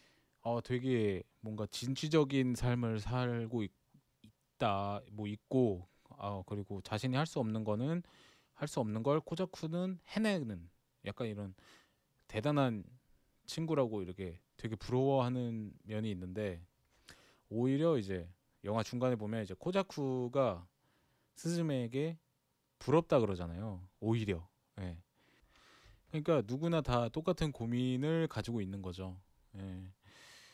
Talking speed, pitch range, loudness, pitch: 255 characters per minute, 100-135 Hz, -37 LUFS, 115 Hz